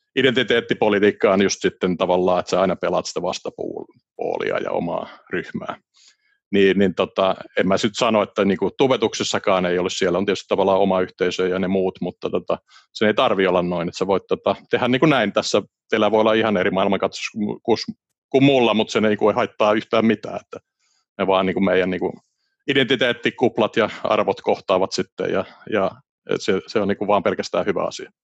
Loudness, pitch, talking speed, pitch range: -20 LUFS, 95 Hz, 185 wpm, 90-110 Hz